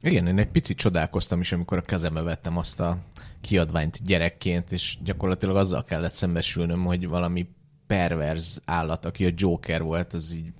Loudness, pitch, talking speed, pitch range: -26 LUFS, 90 Hz, 165 wpm, 85-95 Hz